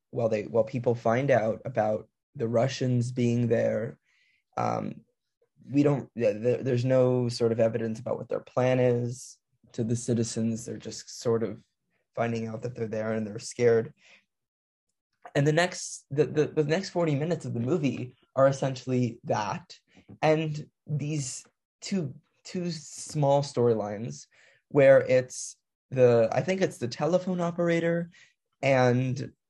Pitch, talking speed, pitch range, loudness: 125 Hz, 145 wpm, 115-145 Hz, -27 LUFS